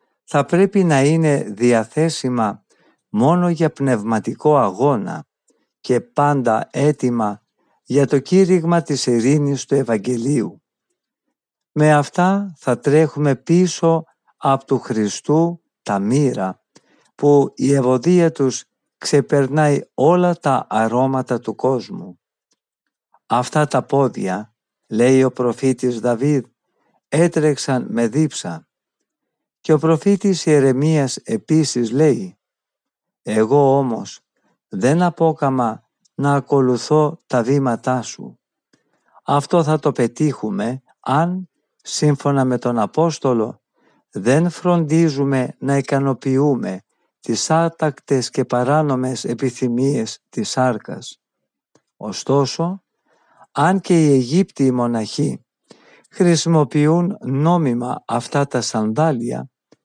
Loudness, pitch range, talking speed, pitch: -18 LUFS, 125-160 Hz, 95 wpm, 140 Hz